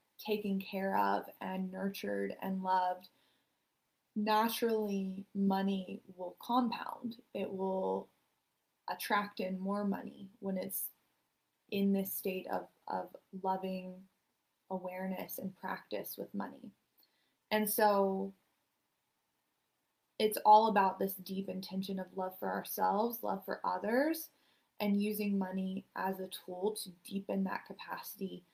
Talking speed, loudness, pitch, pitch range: 115 wpm, -36 LUFS, 195 Hz, 185-210 Hz